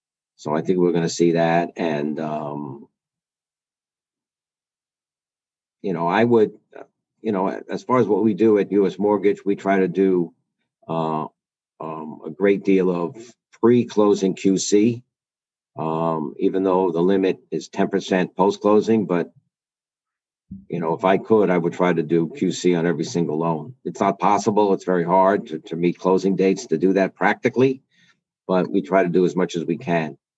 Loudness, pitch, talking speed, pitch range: -20 LUFS, 95 Hz, 175 wpm, 85-100 Hz